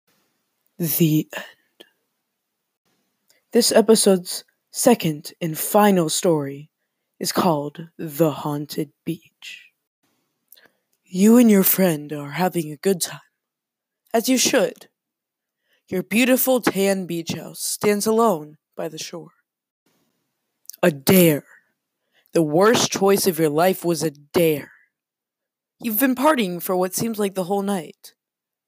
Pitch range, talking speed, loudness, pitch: 160-210 Hz, 115 wpm, -20 LUFS, 185 Hz